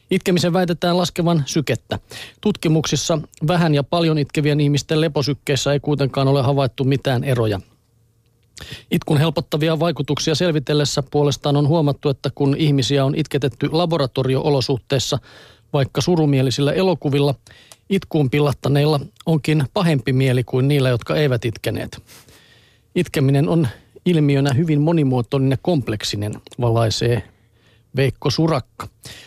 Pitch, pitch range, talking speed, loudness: 145 Hz, 130-160 Hz, 110 wpm, -19 LUFS